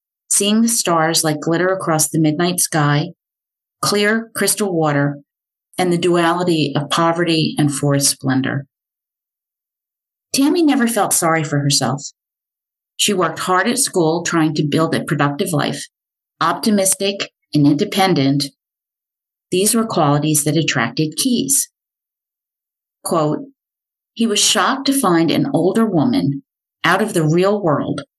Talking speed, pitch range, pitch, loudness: 130 wpm, 150-200 Hz, 165 Hz, -16 LUFS